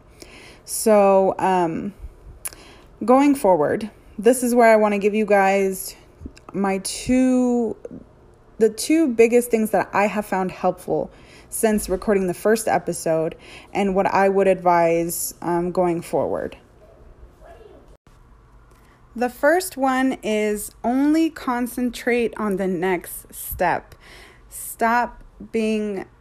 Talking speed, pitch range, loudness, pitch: 110 wpm, 190-240 Hz, -20 LUFS, 210 Hz